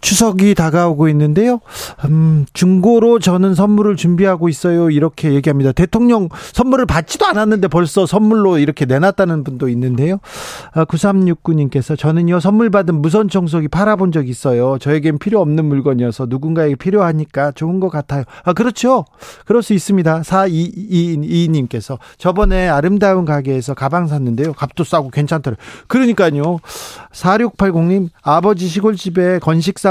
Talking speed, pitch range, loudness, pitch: 345 characters per minute, 150-195 Hz, -14 LUFS, 170 Hz